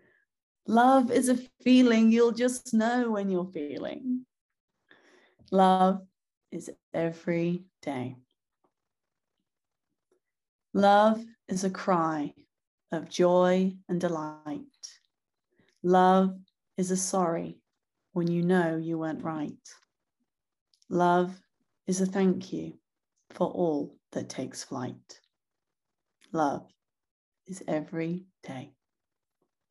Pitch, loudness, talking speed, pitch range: 185 Hz, -27 LUFS, 95 wpm, 170-225 Hz